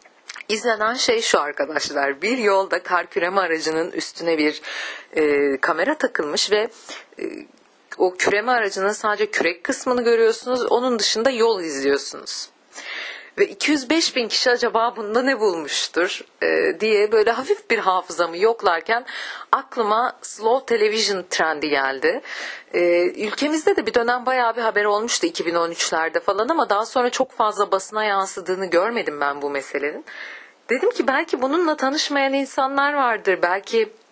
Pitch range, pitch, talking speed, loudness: 185-275 Hz, 225 Hz, 135 wpm, -20 LUFS